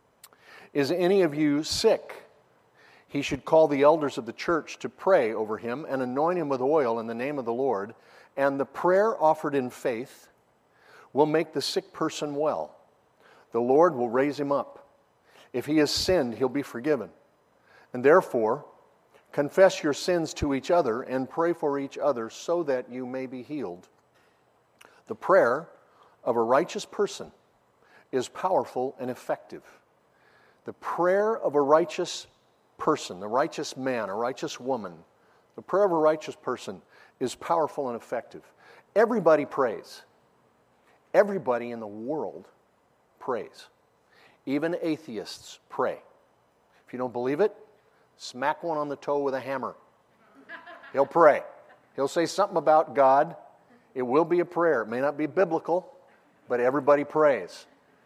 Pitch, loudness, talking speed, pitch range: 150 Hz, -26 LUFS, 150 wpm, 135-170 Hz